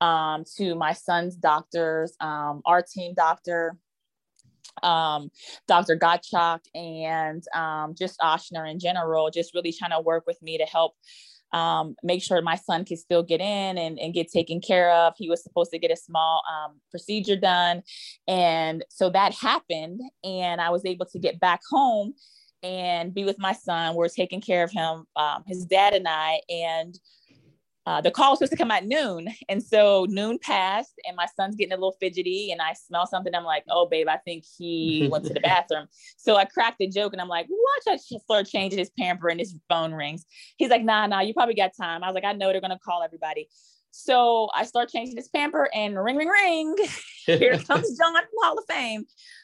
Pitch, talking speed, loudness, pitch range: 180 Hz, 205 wpm, -24 LUFS, 165-205 Hz